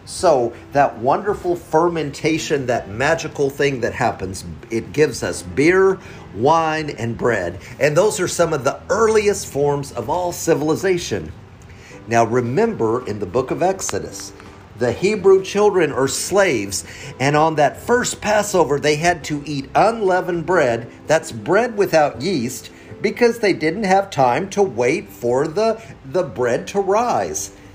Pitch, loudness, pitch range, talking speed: 155 Hz, -19 LUFS, 120-190 Hz, 145 wpm